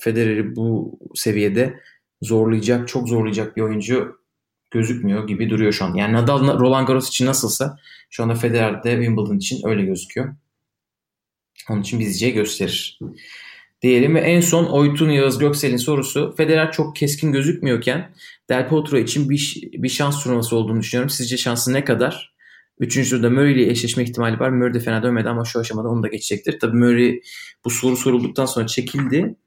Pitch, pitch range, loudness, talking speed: 125 Hz, 115-135 Hz, -19 LUFS, 165 wpm